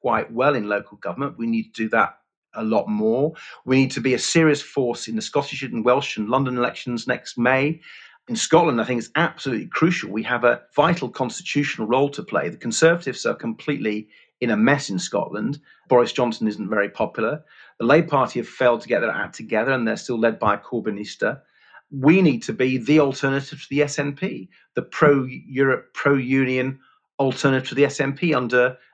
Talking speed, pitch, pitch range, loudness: 195 wpm, 135 Hz, 125-150 Hz, -21 LUFS